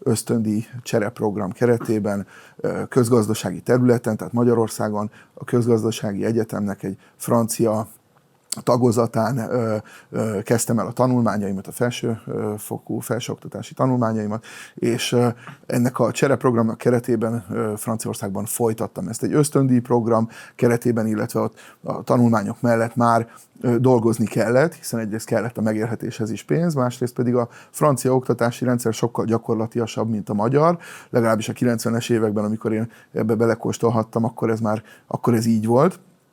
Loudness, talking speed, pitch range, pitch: -21 LUFS, 130 wpm, 110-120 Hz, 115 Hz